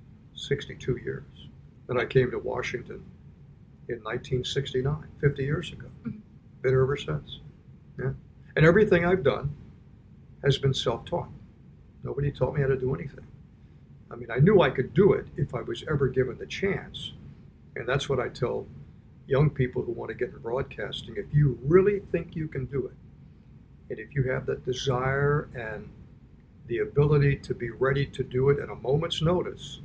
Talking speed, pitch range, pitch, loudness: 170 wpm, 130-150 Hz, 135 Hz, -27 LUFS